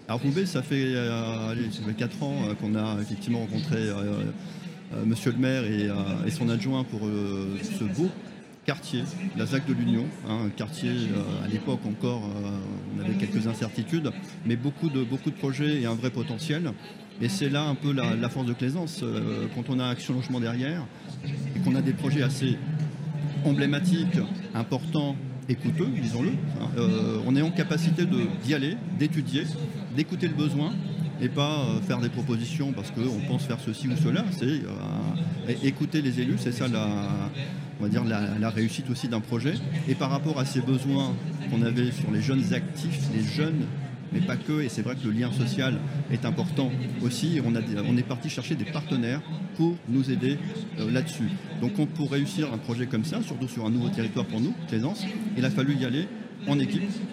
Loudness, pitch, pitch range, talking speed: -28 LUFS, 140 Hz, 120-160 Hz, 185 wpm